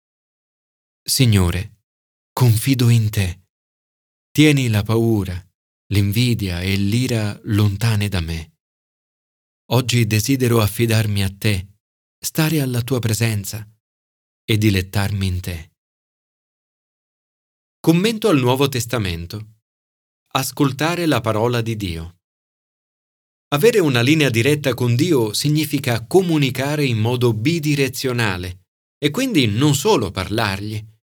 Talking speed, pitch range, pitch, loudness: 100 wpm, 95-130 Hz, 110 Hz, -18 LUFS